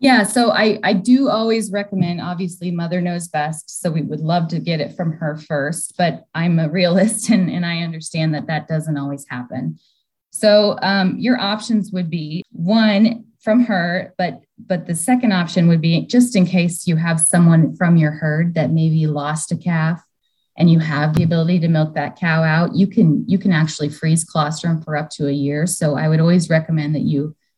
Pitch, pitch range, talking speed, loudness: 170 Hz, 155-190 Hz, 200 wpm, -17 LUFS